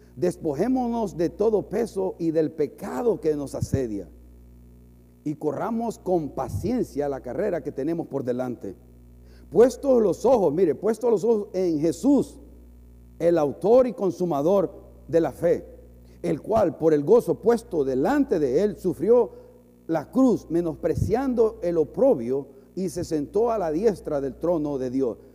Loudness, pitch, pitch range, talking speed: -24 LUFS, 165 Hz, 135-220 Hz, 145 wpm